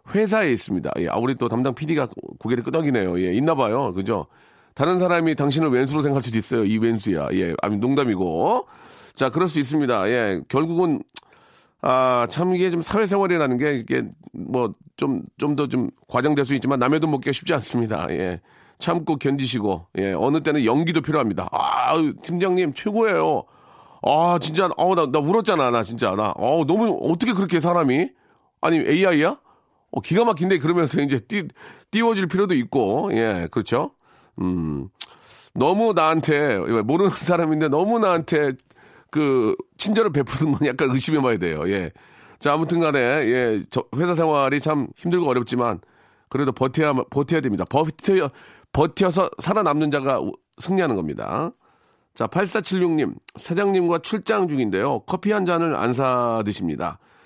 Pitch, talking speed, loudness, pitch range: 155 Hz, 325 characters per minute, -21 LUFS, 130-180 Hz